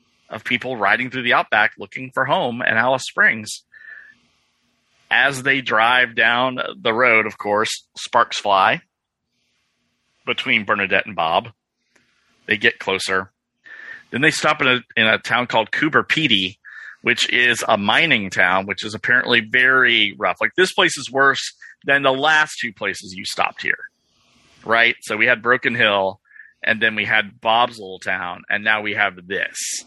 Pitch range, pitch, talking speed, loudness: 105-135 Hz, 120 Hz, 165 wpm, -17 LUFS